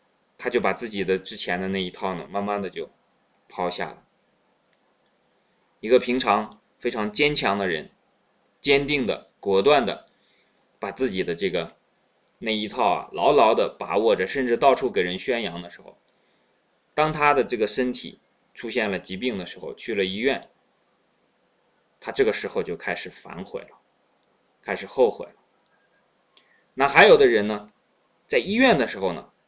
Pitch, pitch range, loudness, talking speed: 120 Hz, 100-150 Hz, -23 LUFS, 225 characters per minute